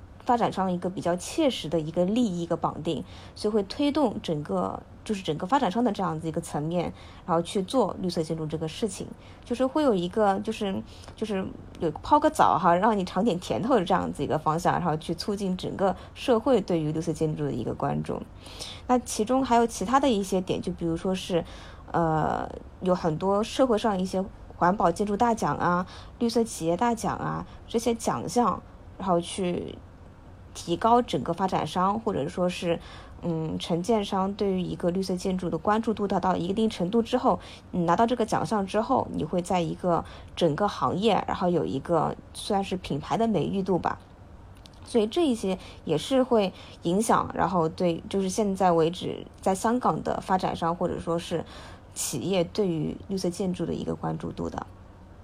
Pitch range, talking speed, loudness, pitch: 165-215 Hz, 280 characters per minute, -27 LUFS, 185 Hz